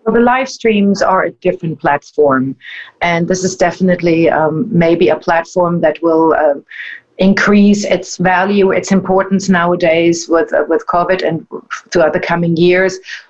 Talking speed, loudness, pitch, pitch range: 155 wpm, -12 LUFS, 180 Hz, 165-190 Hz